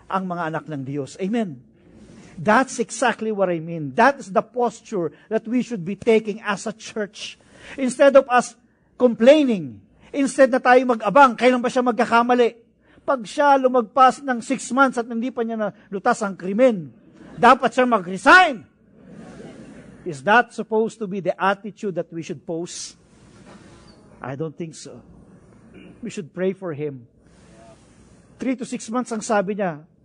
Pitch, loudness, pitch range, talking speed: 220 Hz, -20 LUFS, 190-250 Hz, 160 wpm